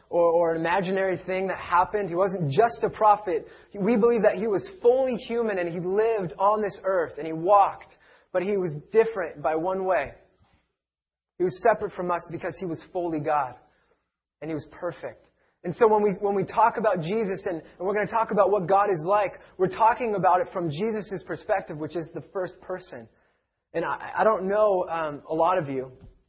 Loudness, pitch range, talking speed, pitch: -25 LUFS, 170-210 Hz, 210 wpm, 190 Hz